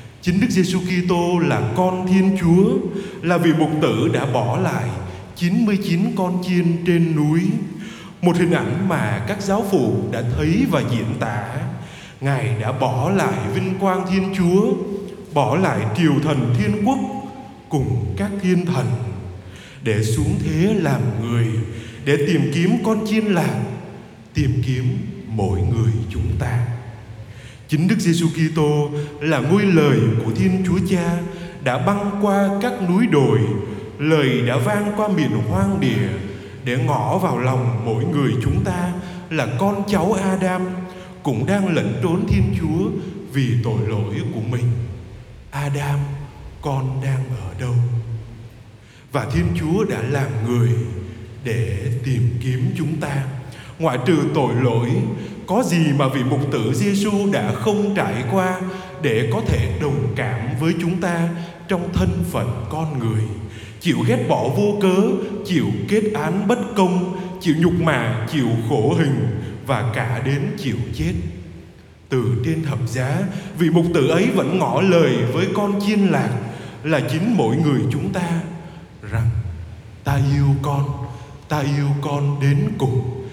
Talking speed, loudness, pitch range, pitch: 150 wpm, -20 LUFS, 120-180 Hz, 145 Hz